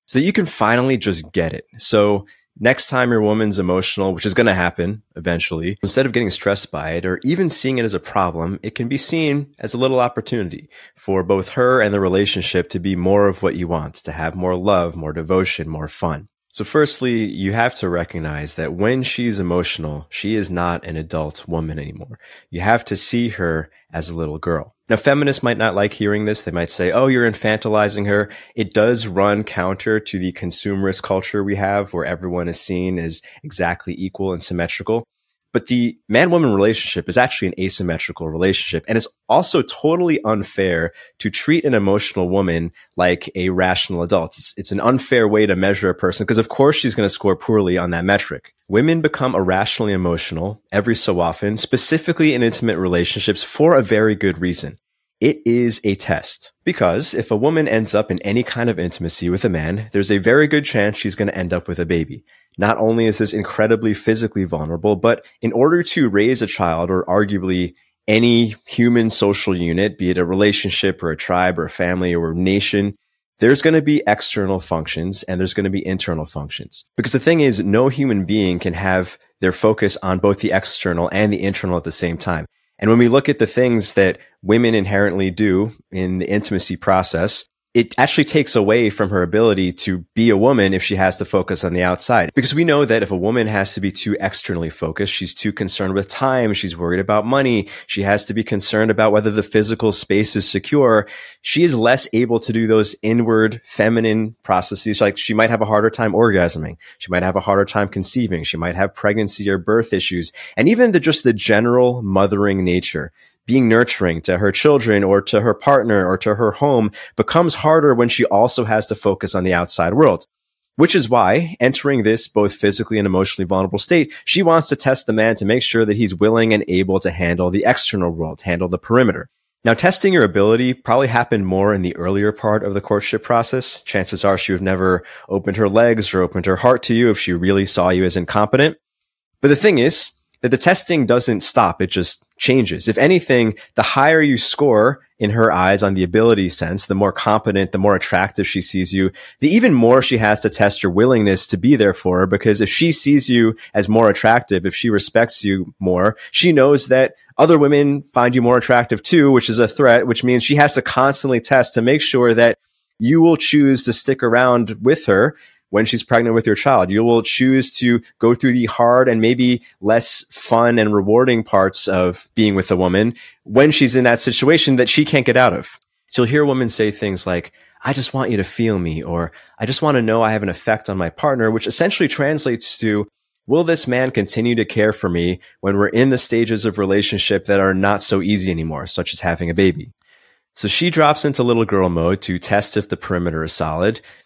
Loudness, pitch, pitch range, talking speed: -16 LUFS, 105 Hz, 95-120 Hz, 210 wpm